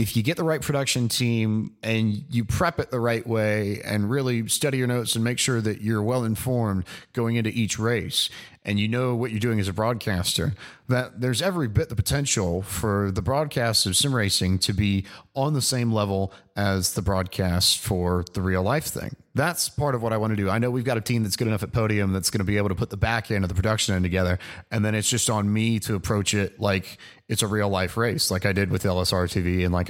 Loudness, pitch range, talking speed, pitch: -24 LUFS, 100-120 Hz, 245 wpm, 110 Hz